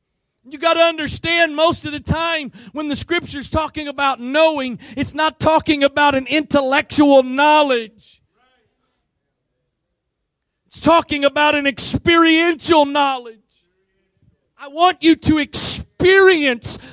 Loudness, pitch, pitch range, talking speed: -15 LUFS, 295 Hz, 270-325 Hz, 110 wpm